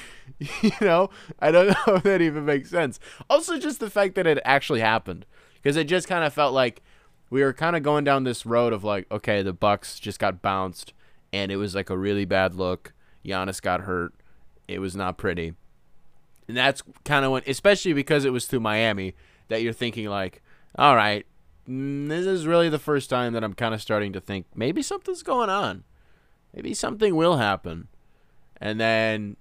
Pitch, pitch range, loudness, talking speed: 115 Hz, 100-155 Hz, -24 LUFS, 195 wpm